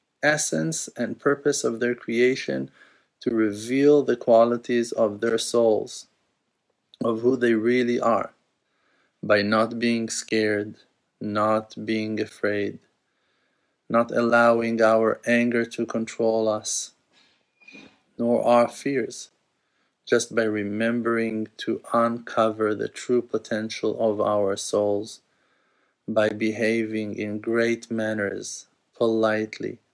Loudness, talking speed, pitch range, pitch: -24 LUFS, 105 wpm, 110-115 Hz, 115 Hz